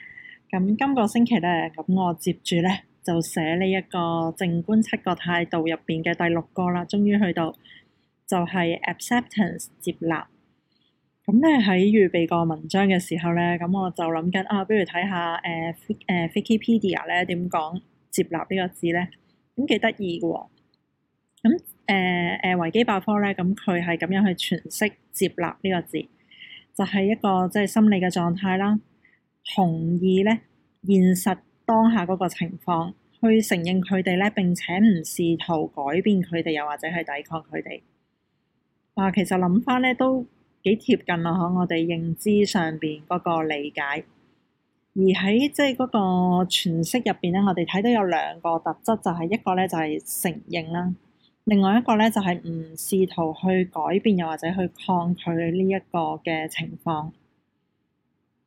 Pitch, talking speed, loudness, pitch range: 180 Hz, 250 characters per minute, -23 LUFS, 170-200 Hz